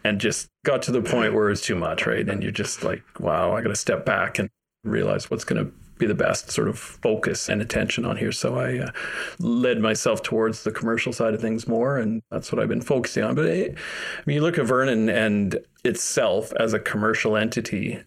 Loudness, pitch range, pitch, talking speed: -24 LUFS, 110-120 Hz, 110 Hz, 230 wpm